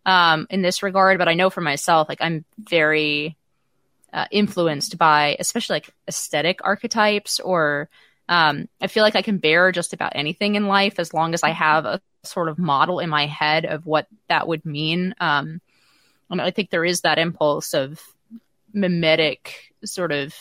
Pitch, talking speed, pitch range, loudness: 170 Hz, 180 wpm, 155-190 Hz, -20 LUFS